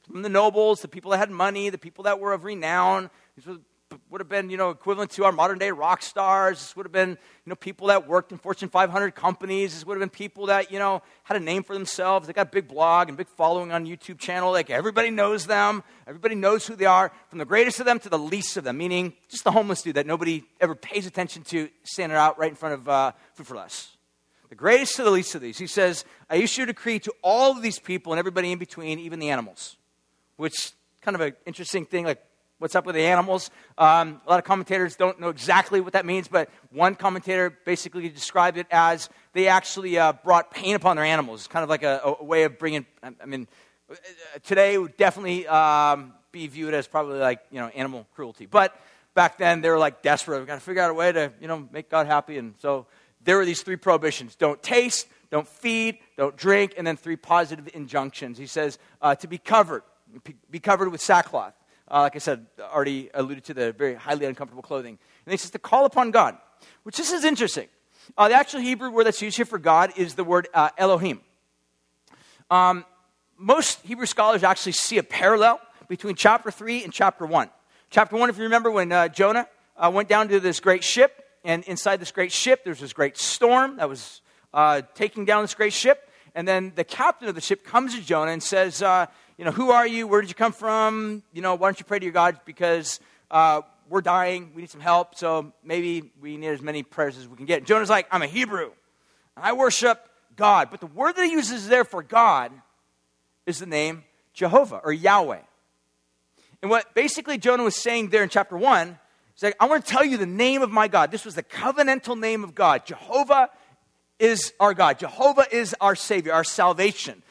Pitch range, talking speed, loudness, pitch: 160-205 Hz, 225 wpm, -22 LUFS, 185 Hz